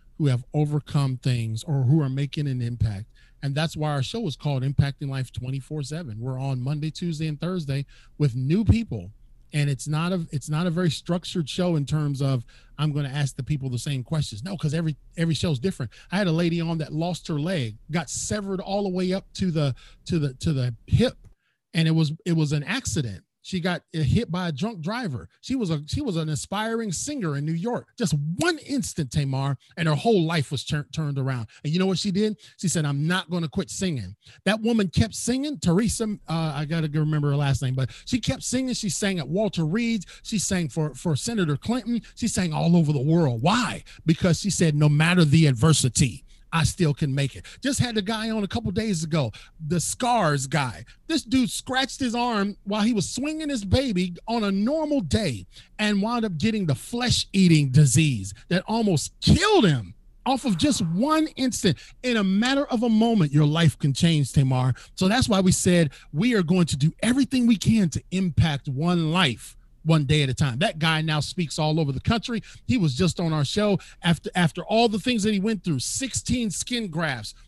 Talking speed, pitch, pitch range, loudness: 220 wpm, 165 Hz, 145-200 Hz, -24 LUFS